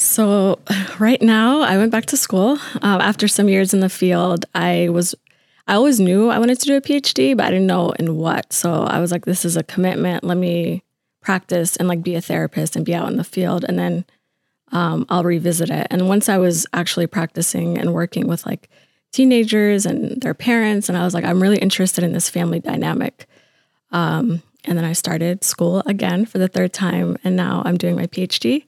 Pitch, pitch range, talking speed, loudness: 180 Hz, 170-205 Hz, 215 wpm, -18 LUFS